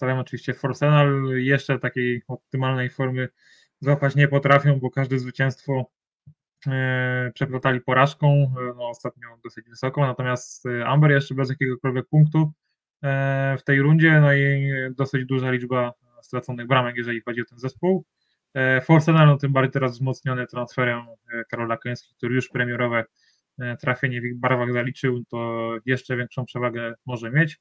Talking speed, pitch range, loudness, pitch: 135 wpm, 125-140 Hz, -22 LUFS, 130 Hz